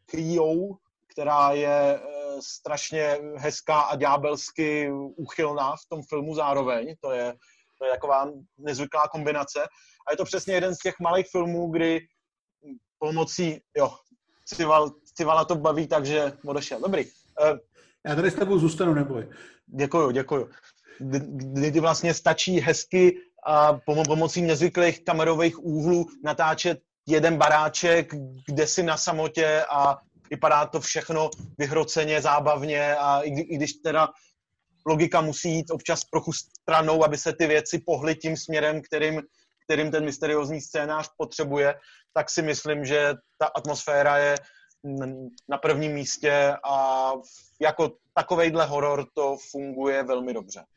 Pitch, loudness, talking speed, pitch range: 155 Hz, -25 LUFS, 130 wpm, 145-165 Hz